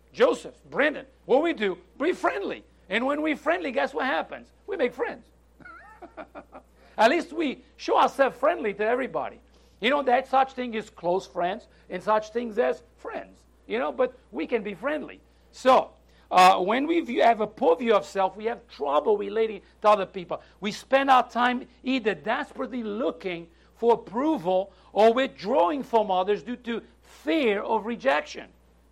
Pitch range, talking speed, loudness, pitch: 205-270 Hz, 170 wpm, -25 LUFS, 235 Hz